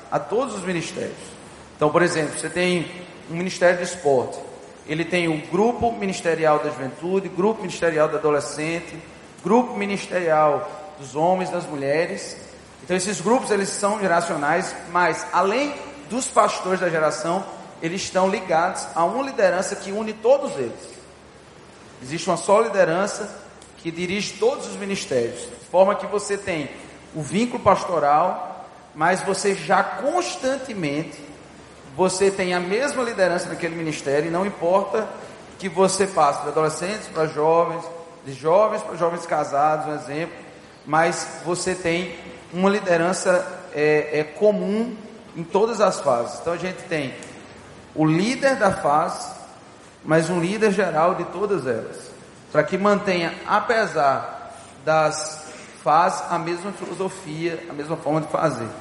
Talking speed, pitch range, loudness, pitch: 140 wpm, 160-200 Hz, -22 LUFS, 180 Hz